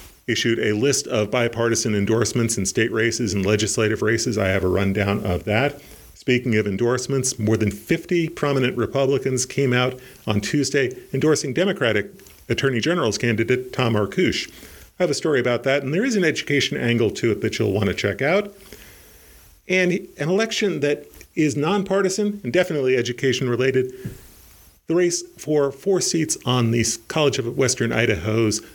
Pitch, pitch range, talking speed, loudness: 125 Hz, 115-150 Hz, 165 wpm, -21 LUFS